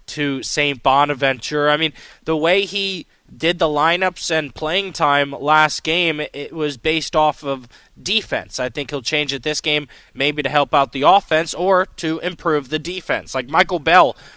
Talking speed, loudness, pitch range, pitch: 180 wpm, -18 LUFS, 145-165 Hz, 150 Hz